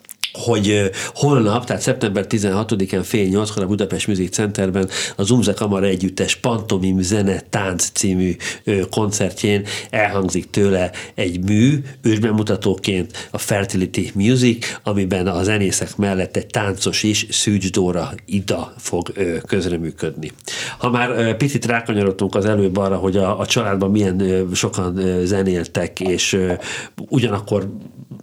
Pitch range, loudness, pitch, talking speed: 95-110 Hz, -19 LUFS, 100 Hz, 120 wpm